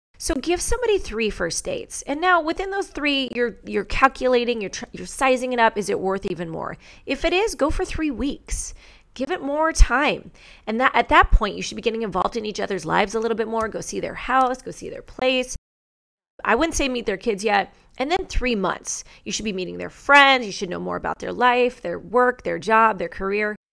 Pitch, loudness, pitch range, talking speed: 245 Hz, -22 LUFS, 210-280 Hz, 230 wpm